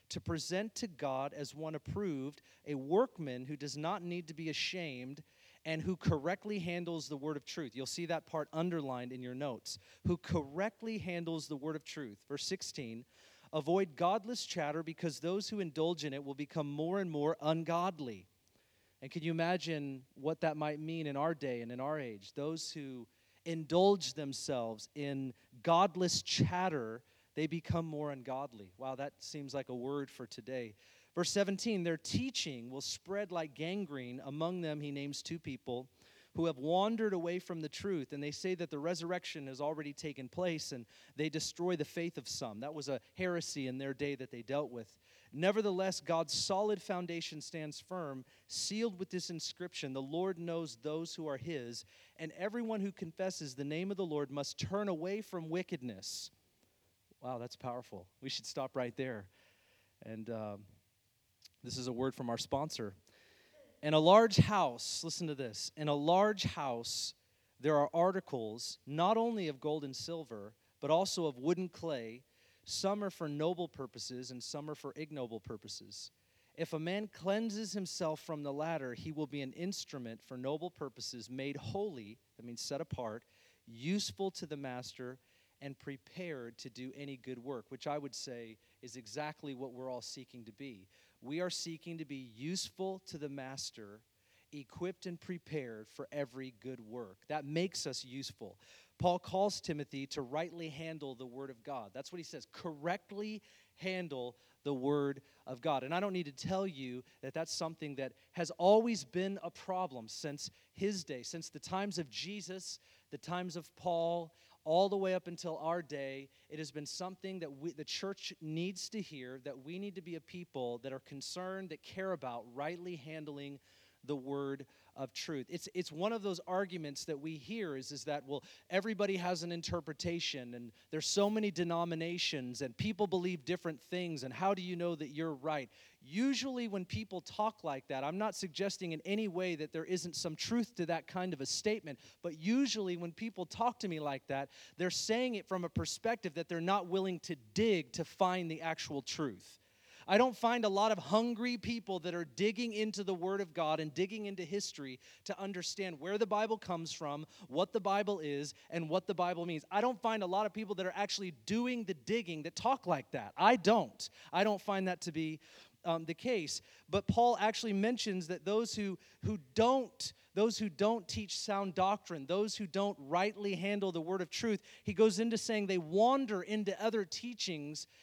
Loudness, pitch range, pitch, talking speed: -38 LUFS, 135-185 Hz, 160 Hz, 185 wpm